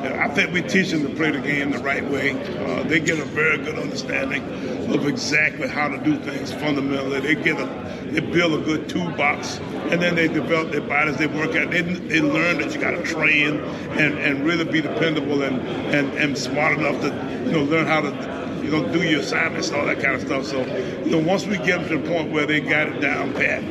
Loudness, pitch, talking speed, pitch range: -21 LUFS, 150 Hz, 235 wpm, 140-170 Hz